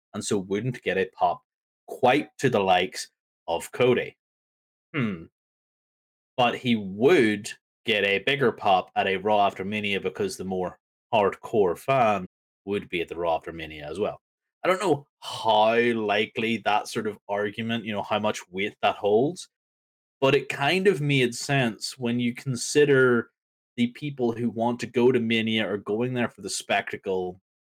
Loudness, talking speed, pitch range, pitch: -25 LUFS, 170 wpm, 100-120 Hz, 115 Hz